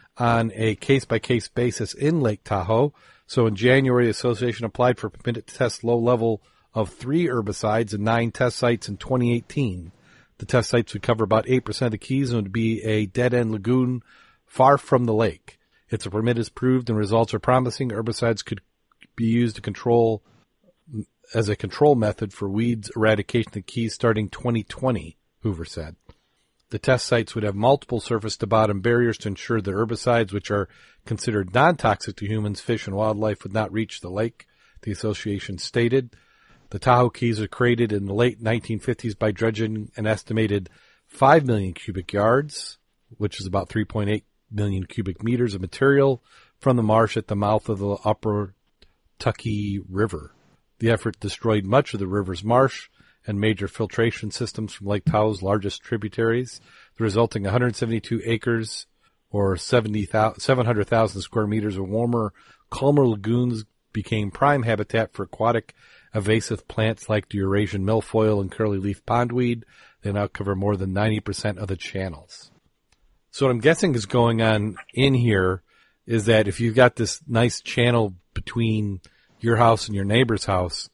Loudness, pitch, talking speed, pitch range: -23 LUFS, 110 Hz, 160 wpm, 105-120 Hz